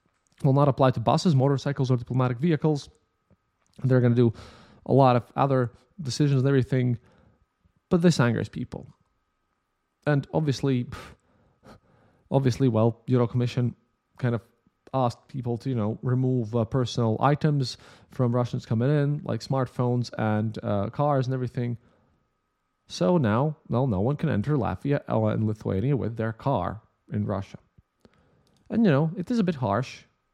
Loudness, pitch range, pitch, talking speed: -25 LUFS, 110-135 Hz, 125 Hz, 150 wpm